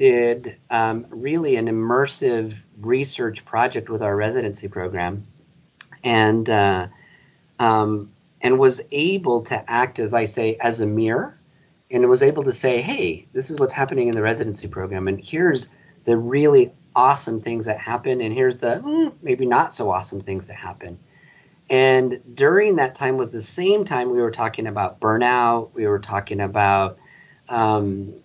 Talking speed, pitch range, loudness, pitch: 160 wpm, 105-140 Hz, -20 LUFS, 115 Hz